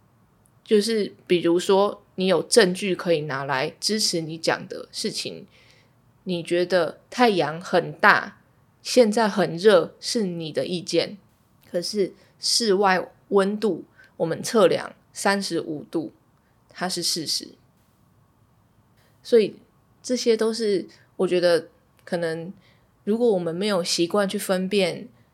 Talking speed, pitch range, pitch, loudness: 180 characters per minute, 165-205 Hz, 180 Hz, -23 LUFS